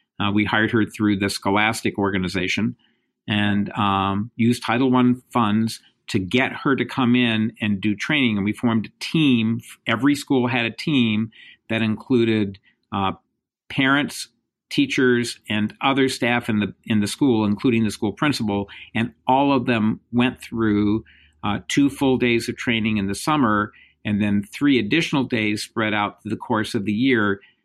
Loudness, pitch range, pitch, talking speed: -21 LUFS, 105-125 Hz, 110 Hz, 170 wpm